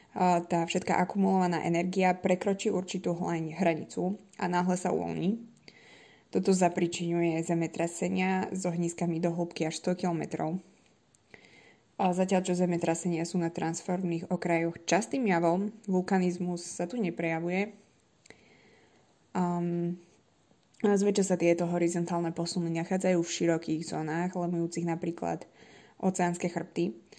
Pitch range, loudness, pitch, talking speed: 170-185 Hz, -30 LUFS, 175 Hz, 110 wpm